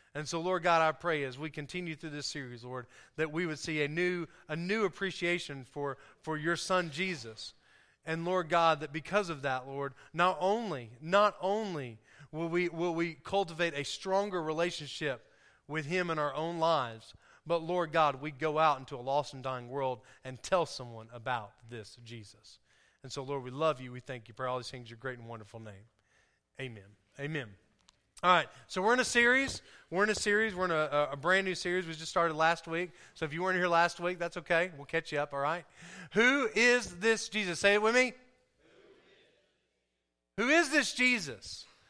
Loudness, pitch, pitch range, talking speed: -32 LUFS, 160 Hz, 130-180 Hz, 205 wpm